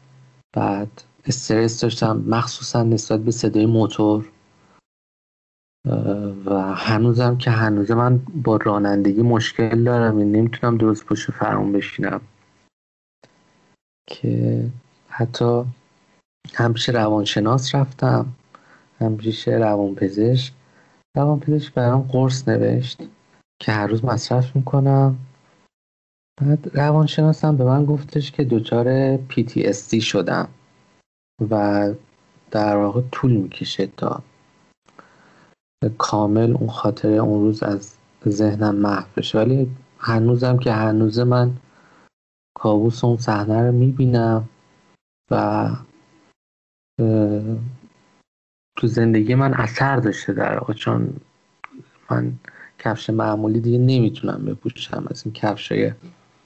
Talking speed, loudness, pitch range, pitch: 100 wpm, -20 LUFS, 105-125 Hz, 115 Hz